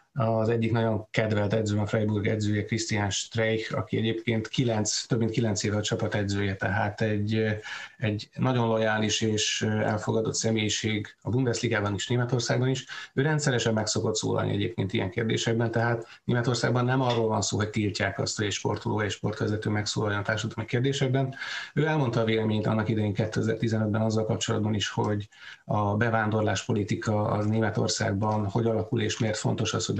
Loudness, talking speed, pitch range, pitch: -27 LUFS, 160 wpm, 105-115 Hz, 110 Hz